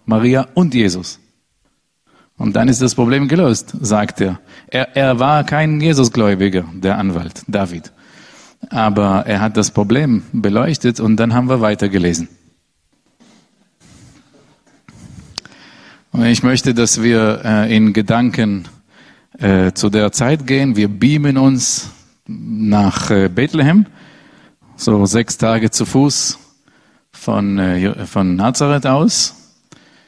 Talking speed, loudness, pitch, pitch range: 120 wpm, -14 LUFS, 110 Hz, 100-130 Hz